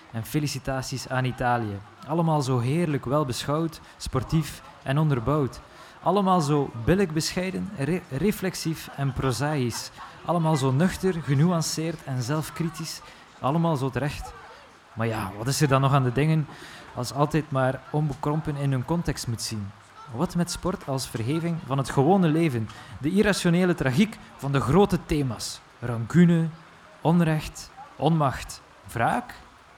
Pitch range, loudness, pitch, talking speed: 130-165 Hz, -25 LUFS, 150 Hz, 135 wpm